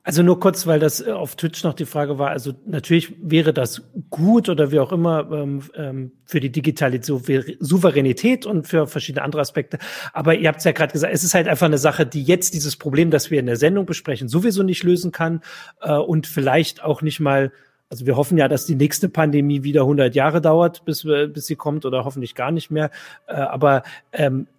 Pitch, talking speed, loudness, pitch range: 155 Hz, 210 wpm, -19 LUFS, 140-165 Hz